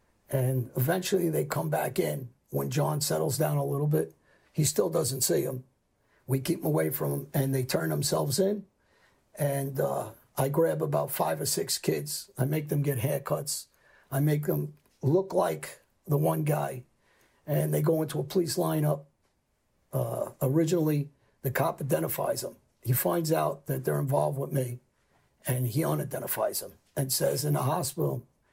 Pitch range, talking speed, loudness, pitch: 130-155 Hz, 170 wpm, -29 LUFS, 140 Hz